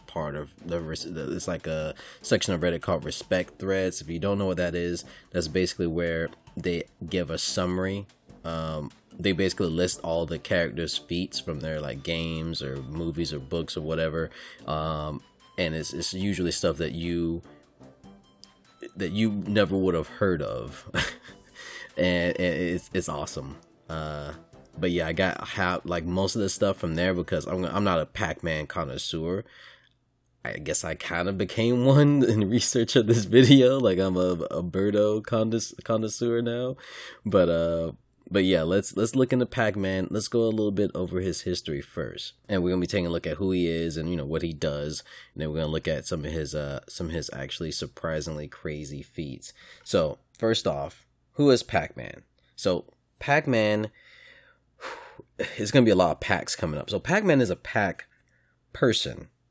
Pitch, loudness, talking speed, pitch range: 90 Hz, -27 LUFS, 180 wpm, 80-105 Hz